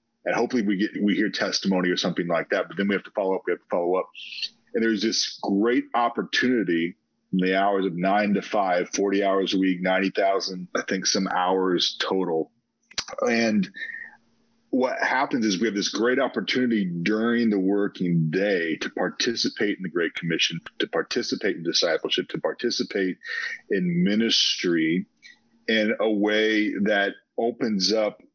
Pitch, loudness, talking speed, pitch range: 100 Hz, -24 LUFS, 165 wpm, 95-115 Hz